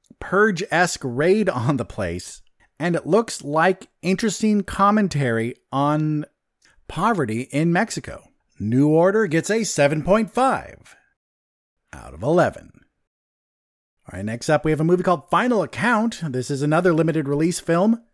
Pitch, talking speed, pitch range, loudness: 165 Hz, 135 wpm, 140-195 Hz, -21 LUFS